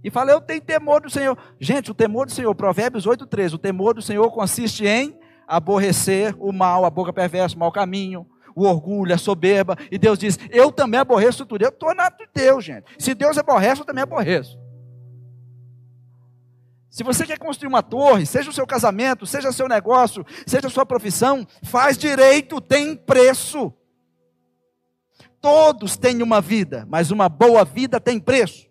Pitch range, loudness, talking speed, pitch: 180-265 Hz, -18 LUFS, 180 wpm, 220 Hz